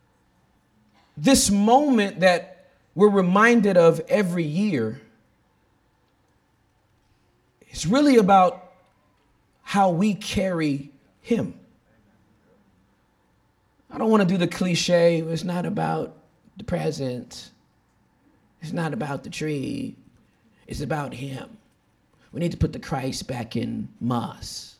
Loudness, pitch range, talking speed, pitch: -22 LUFS, 125-200 Hz, 105 wpm, 170 Hz